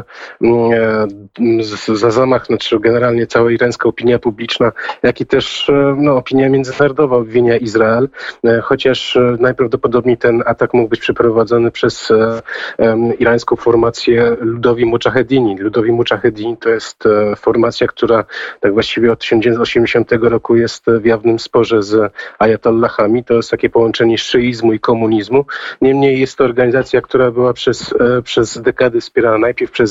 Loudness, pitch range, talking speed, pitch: -13 LUFS, 115-125 Hz, 130 wpm, 120 Hz